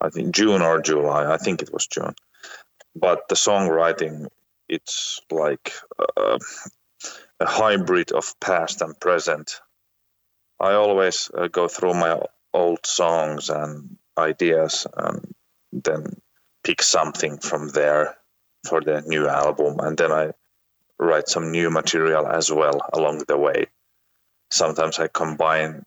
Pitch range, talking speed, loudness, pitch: 75-95 Hz, 130 wpm, -21 LUFS, 80 Hz